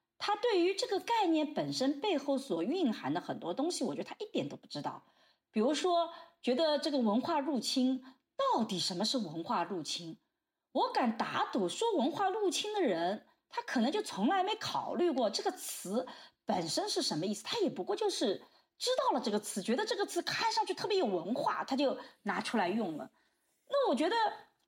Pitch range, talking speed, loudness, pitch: 260-395 Hz, 280 characters per minute, -34 LUFS, 320 Hz